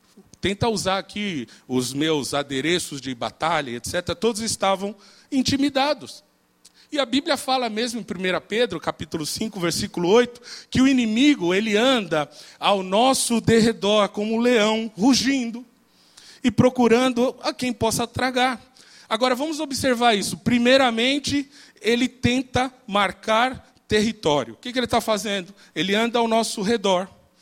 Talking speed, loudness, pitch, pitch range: 135 wpm, -22 LUFS, 225 Hz, 195-255 Hz